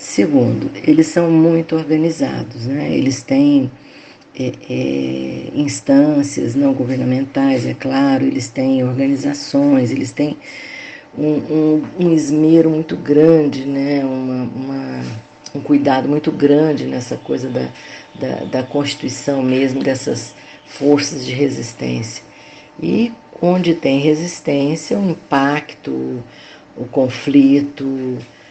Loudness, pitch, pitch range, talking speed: -16 LUFS, 140 Hz, 130-155 Hz, 115 wpm